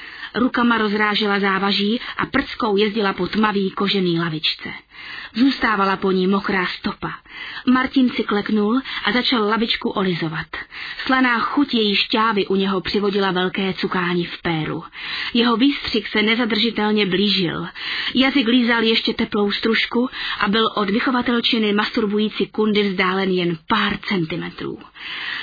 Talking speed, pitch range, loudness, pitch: 125 wpm, 195-235 Hz, -19 LUFS, 210 Hz